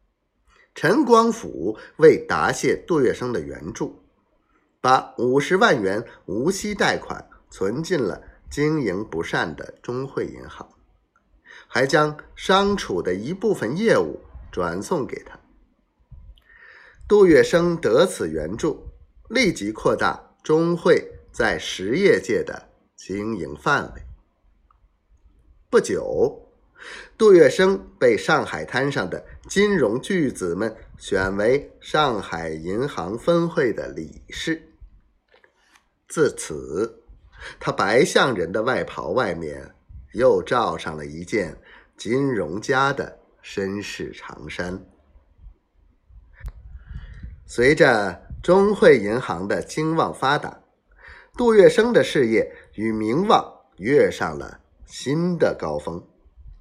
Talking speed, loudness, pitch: 155 characters per minute, -21 LUFS, 170 Hz